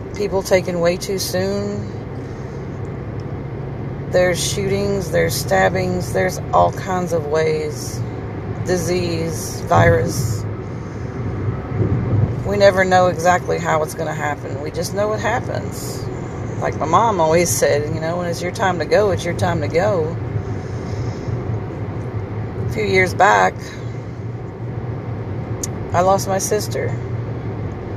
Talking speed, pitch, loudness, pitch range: 120 wpm, 125 Hz, -20 LUFS, 115-155 Hz